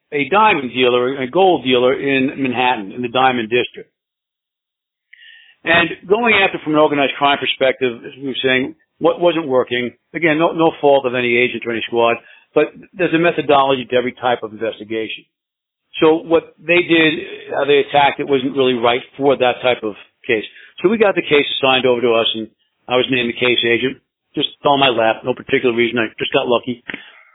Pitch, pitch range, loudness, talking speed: 130 Hz, 125-160 Hz, -16 LUFS, 195 wpm